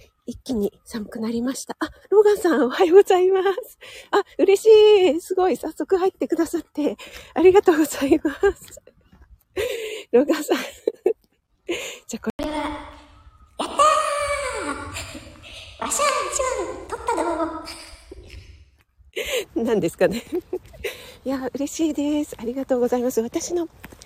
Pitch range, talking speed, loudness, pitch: 275-400 Hz, 260 characters per minute, -21 LUFS, 325 Hz